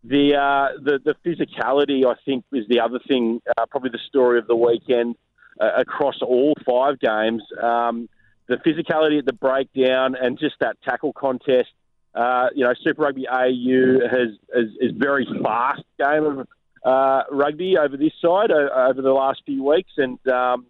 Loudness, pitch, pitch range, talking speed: -20 LUFS, 130 Hz, 125-140 Hz, 175 wpm